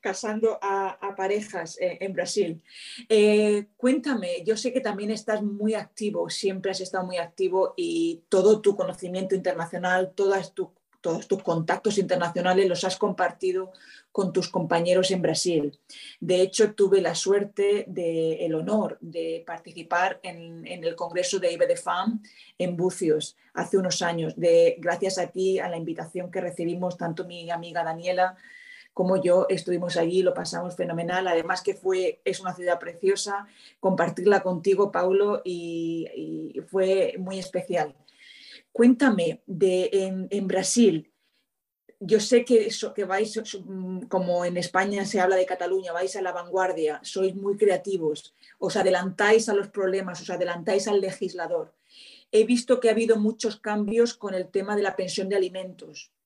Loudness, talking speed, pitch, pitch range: -25 LUFS, 155 wpm, 190 Hz, 180-210 Hz